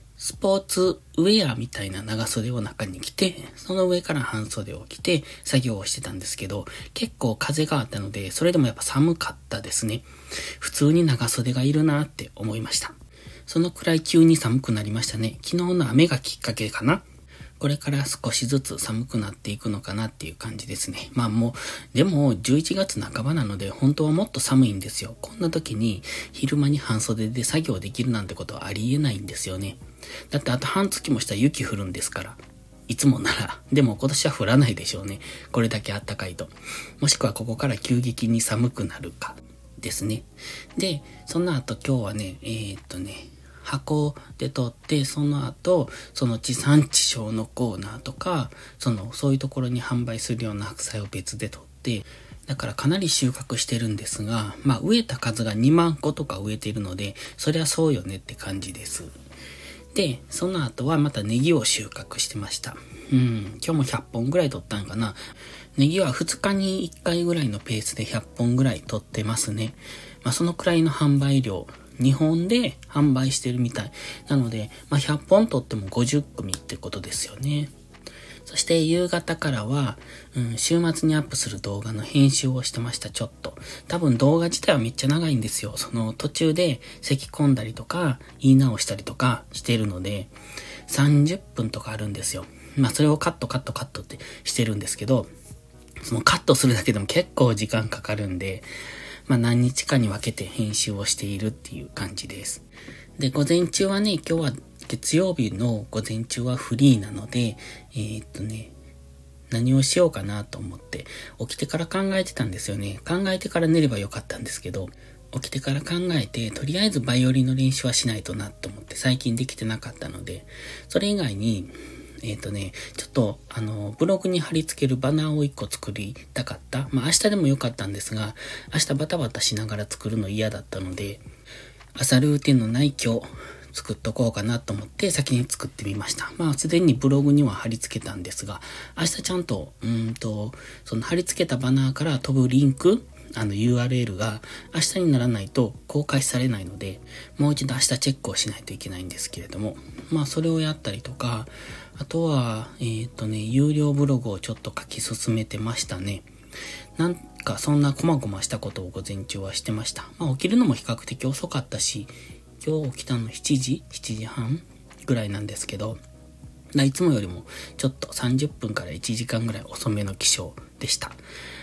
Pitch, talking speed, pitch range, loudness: 125 Hz, 360 characters per minute, 110-145 Hz, -24 LUFS